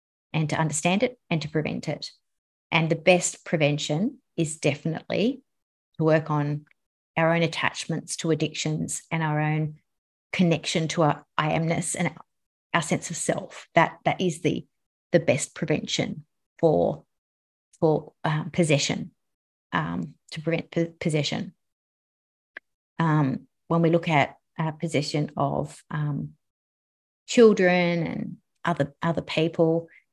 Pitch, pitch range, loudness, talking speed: 160 Hz, 150-170 Hz, -25 LUFS, 130 wpm